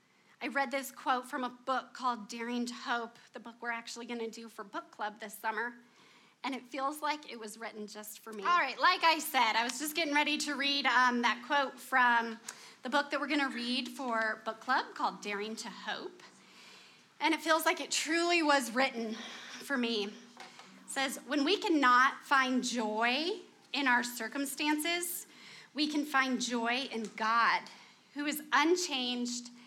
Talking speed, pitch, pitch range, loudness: 185 wpm, 255 Hz, 235-290 Hz, -32 LUFS